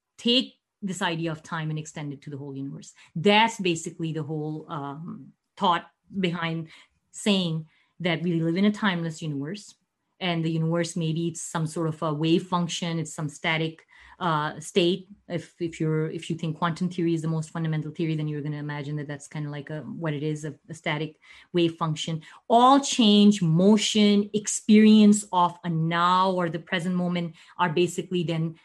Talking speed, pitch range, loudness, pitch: 185 wpm, 155-185 Hz, -25 LUFS, 170 Hz